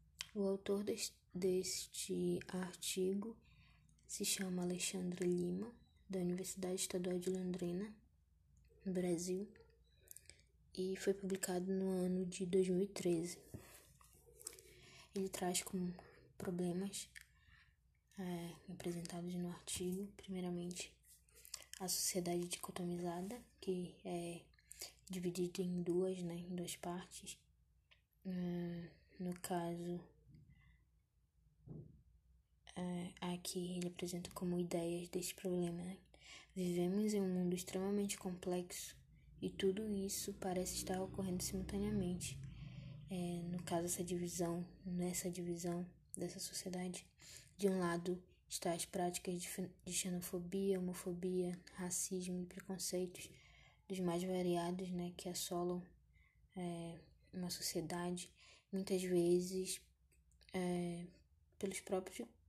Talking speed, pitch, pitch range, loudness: 95 wpm, 180 Hz, 175-190 Hz, -43 LUFS